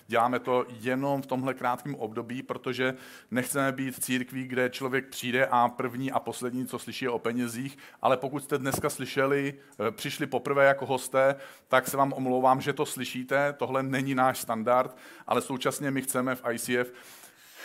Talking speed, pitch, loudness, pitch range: 170 wpm, 130 Hz, -29 LUFS, 125-135 Hz